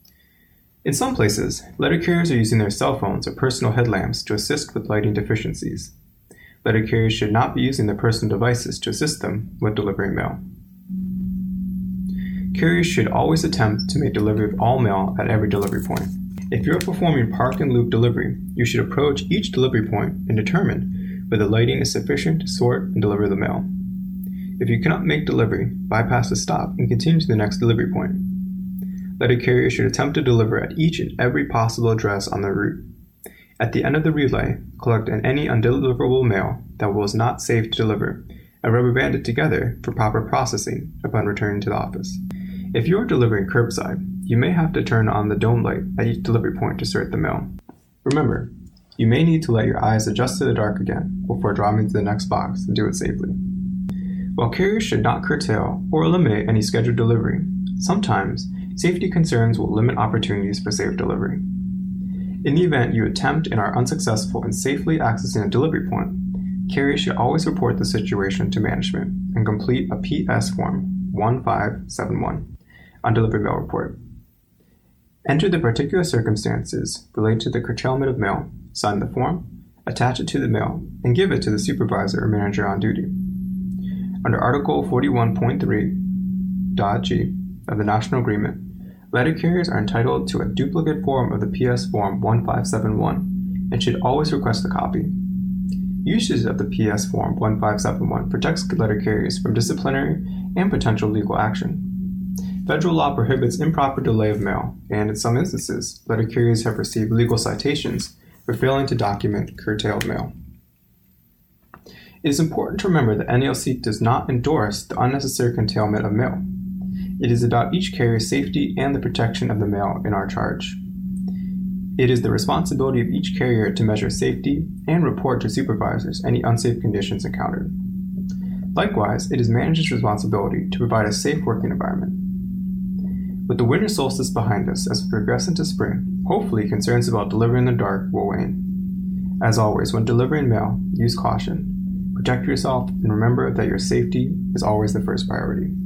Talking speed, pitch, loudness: 175 wpm, 125 Hz, -21 LUFS